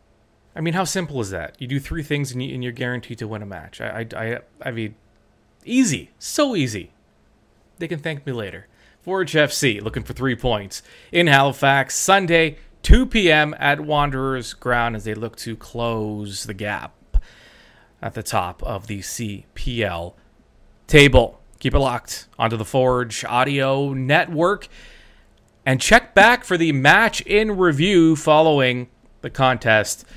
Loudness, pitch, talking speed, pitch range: -19 LUFS, 130 Hz, 155 wpm, 110-155 Hz